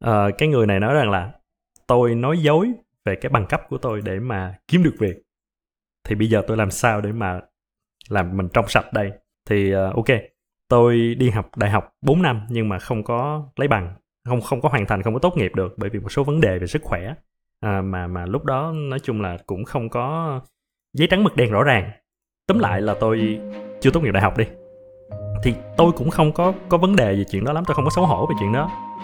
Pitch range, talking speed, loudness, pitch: 105-150 Hz, 240 wpm, -20 LUFS, 115 Hz